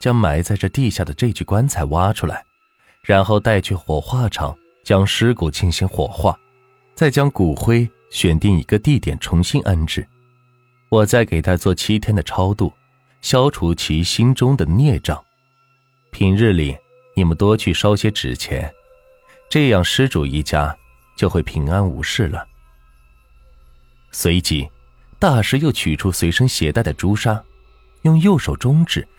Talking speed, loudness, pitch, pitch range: 210 characters per minute, -17 LUFS, 100 Hz, 85-130 Hz